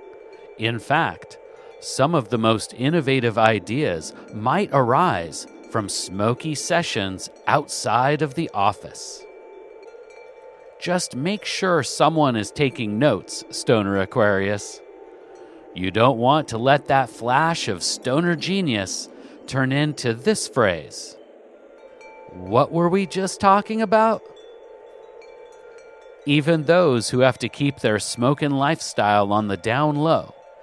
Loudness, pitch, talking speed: -21 LUFS, 170 Hz, 115 wpm